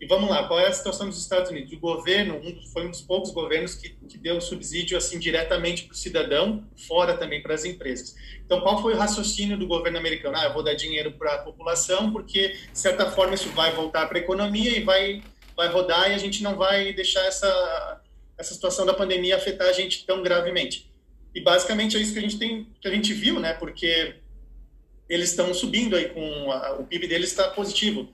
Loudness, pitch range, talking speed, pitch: -24 LUFS, 165-195 Hz, 220 wpm, 180 Hz